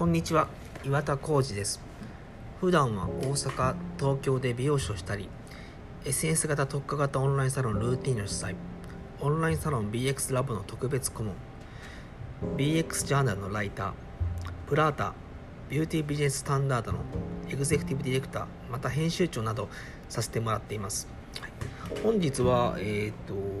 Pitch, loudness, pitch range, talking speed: 135 Hz, -30 LUFS, 105-145 Hz, 350 characters per minute